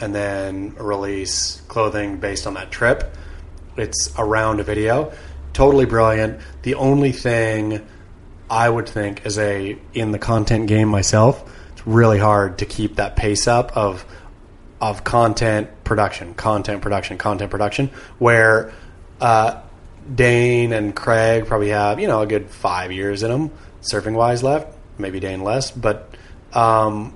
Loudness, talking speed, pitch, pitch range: -19 LUFS, 150 wpm, 105 Hz, 100-115 Hz